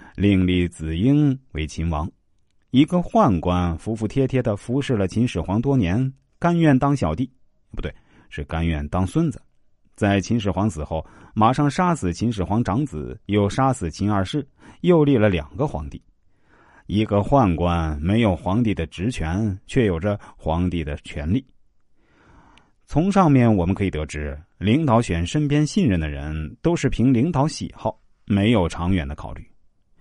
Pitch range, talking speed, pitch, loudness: 85-130 Hz, 230 characters per minute, 100 Hz, -21 LUFS